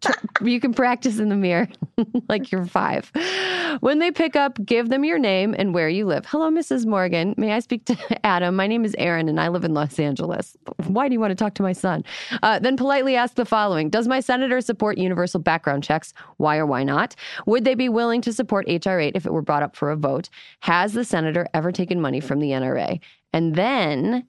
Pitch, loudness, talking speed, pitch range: 210 Hz, -22 LUFS, 225 wpm, 170-245 Hz